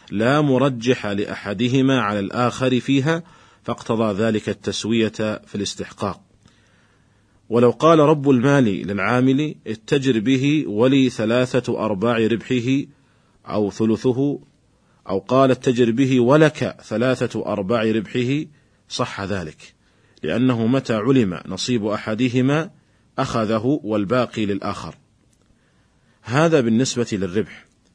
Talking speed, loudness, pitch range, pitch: 95 wpm, -20 LUFS, 110-130 Hz, 120 Hz